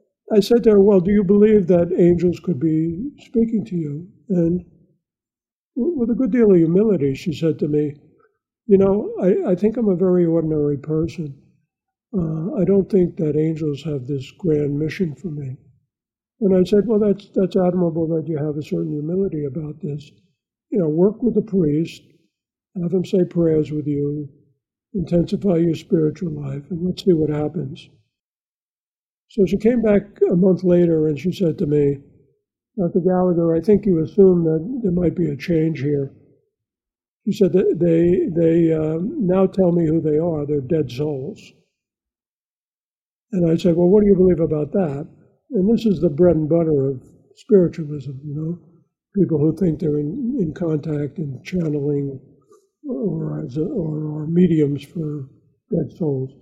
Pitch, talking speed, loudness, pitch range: 170 Hz, 175 wpm, -19 LUFS, 150-190 Hz